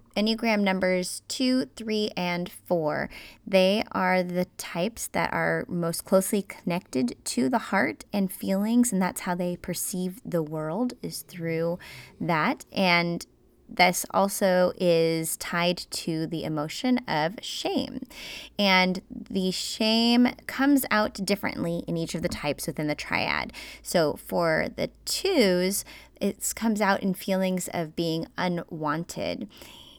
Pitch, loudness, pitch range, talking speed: 185 Hz, -26 LUFS, 170-210 Hz, 130 wpm